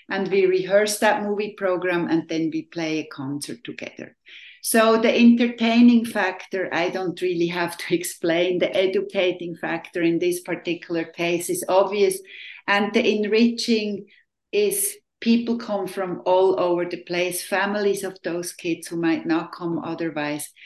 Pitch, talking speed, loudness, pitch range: 185 Hz, 150 wpm, -22 LUFS, 170-210 Hz